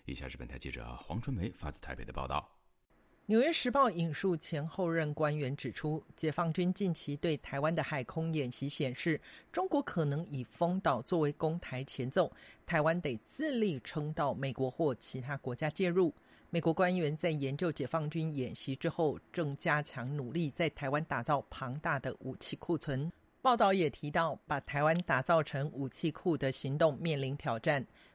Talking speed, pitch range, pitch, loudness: 270 characters per minute, 135-170 Hz, 155 Hz, -34 LUFS